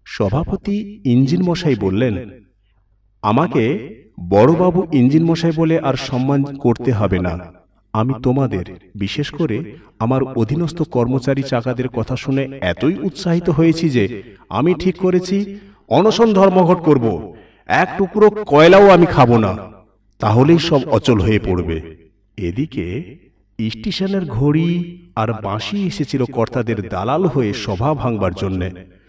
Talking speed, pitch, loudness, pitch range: 120 wpm, 130 Hz, -16 LUFS, 105-170 Hz